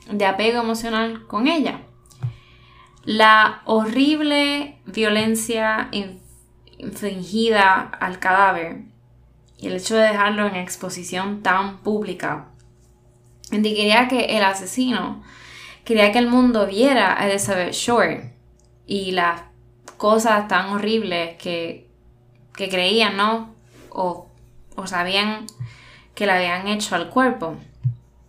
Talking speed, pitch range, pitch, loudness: 105 wpm, 170-220 Hz, 200 Hz, -19 LUFS